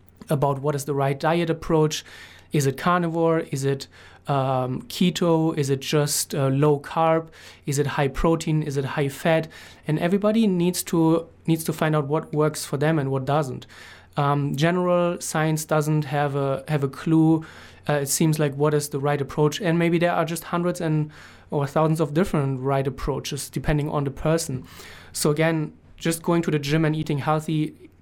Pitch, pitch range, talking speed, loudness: 155 Hz, 145-165 Hz, 190 wpm, -23 LUFS